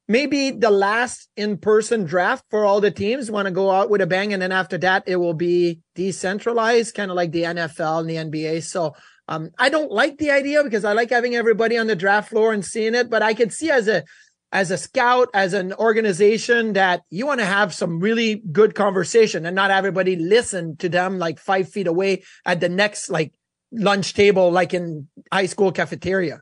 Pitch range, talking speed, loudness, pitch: 180-225 Hz, 215 wpm, -20 LUFS, 200 Hz